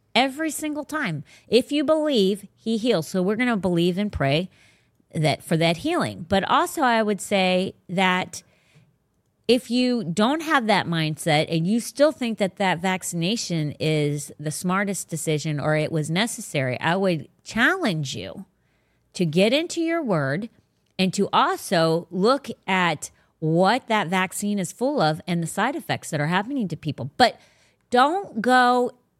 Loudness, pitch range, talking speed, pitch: -23 LUFS, 165-240 Hz, 160 wpm, 190 Hz